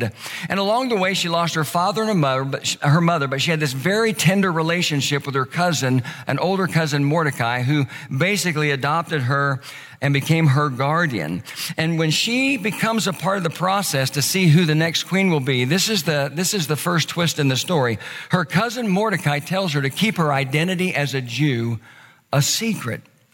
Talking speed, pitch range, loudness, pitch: 205 wpm, 140-185 Hz, -20 LUFS, 160 Hz